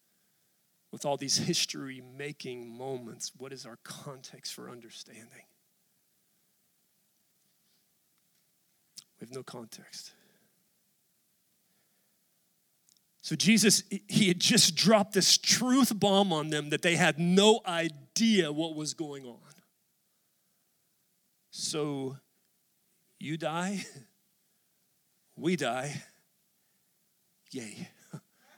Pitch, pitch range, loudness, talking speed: 180 Hz, 150-200 Hz, -27 LUFS, 90 wpm